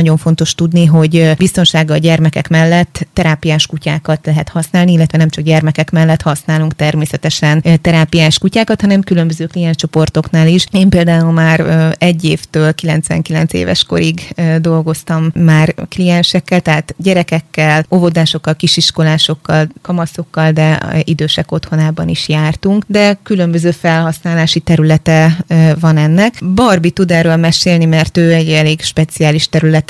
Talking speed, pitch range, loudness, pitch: 125 wpm, 155-170 Hz, -11 LUFS, 160 Hz